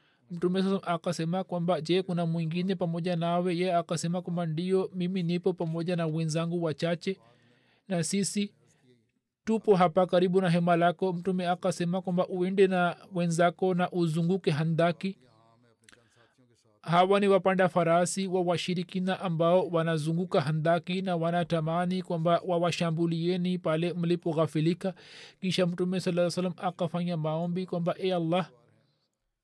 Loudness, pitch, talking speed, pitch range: -28 LUFS, 175 Hz, 105 wpm, 165-185 Hz